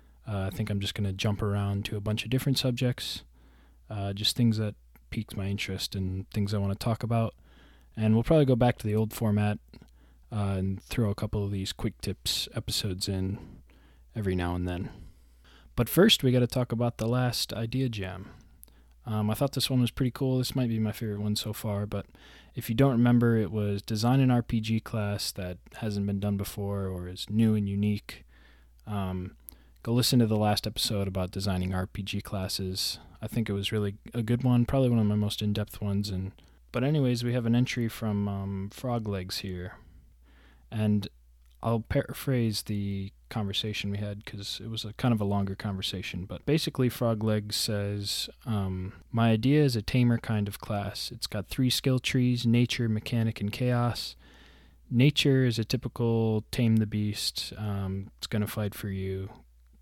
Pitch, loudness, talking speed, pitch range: 105 Hz, -29 LUFS, 190 wpm, 95-115 Hz